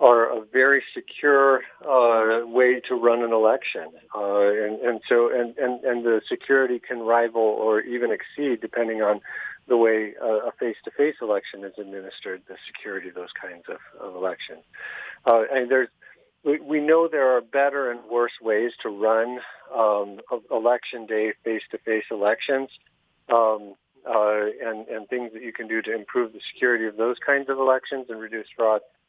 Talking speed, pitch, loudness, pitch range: 170 wpm, 115 Hz, -23 LUFS, 110-125 Hz